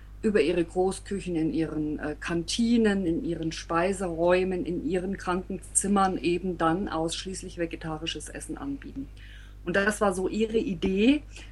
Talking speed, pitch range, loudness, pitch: 125 wpm, 165-200 Hz, -28 LUFS, 185 Hz